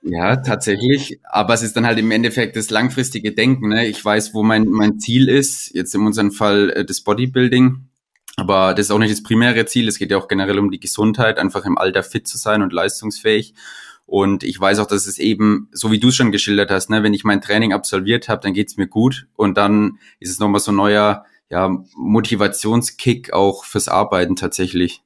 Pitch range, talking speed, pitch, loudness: 100-115 Hz, 220 wpm, 105 Hz, -16 LUFS